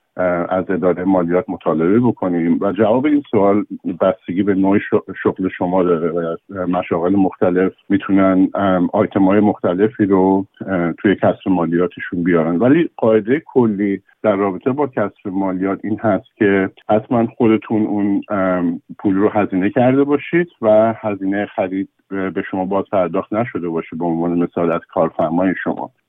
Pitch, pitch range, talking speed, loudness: 95 Hz, 90-105 Hz, 145 wpm, -17 LUFS